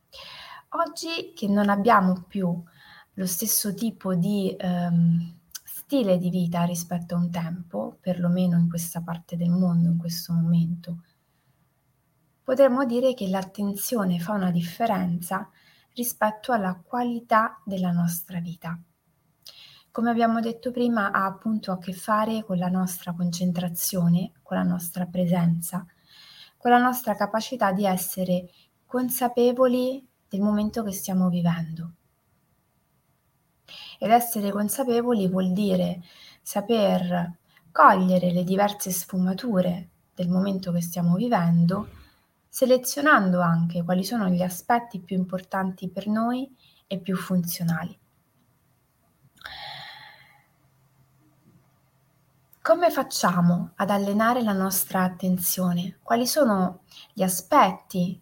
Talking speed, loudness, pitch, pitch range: 110 wpm, -24 LUFS, 185 Hz, 175-215 Hz